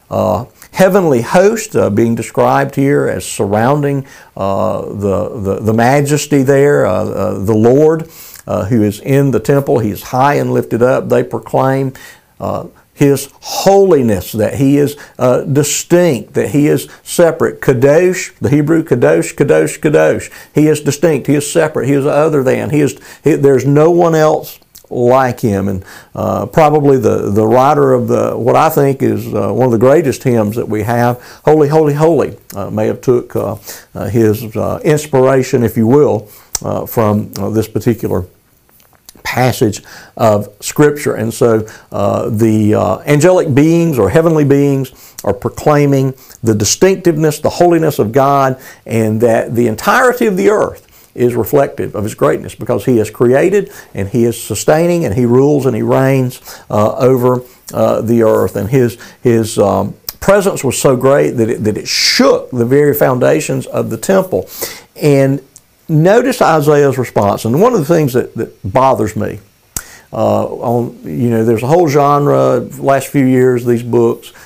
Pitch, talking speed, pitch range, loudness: 130 Hz, 170 wpm, 110-150 Hz, -12 LUFS